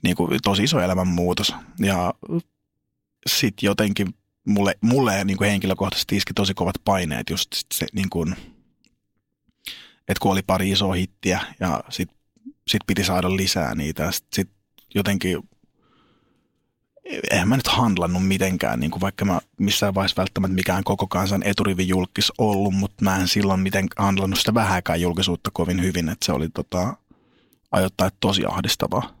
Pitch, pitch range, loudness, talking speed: 95 Hz, 90-100 Hz, -22 LUFS, 145 wpm